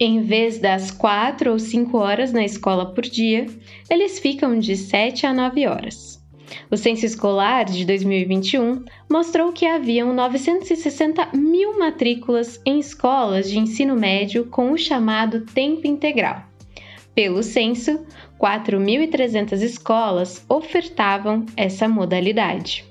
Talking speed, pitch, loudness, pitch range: 120 wpm, 235 Hz, -20 LUFS, 205-280 Hz